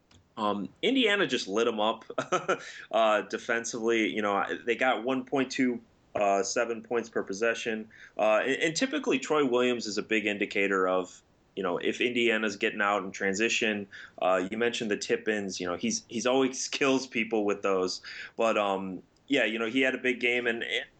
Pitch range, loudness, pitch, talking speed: 100-125 Hz, -28 LUFS, 115 Hz, 185 wpm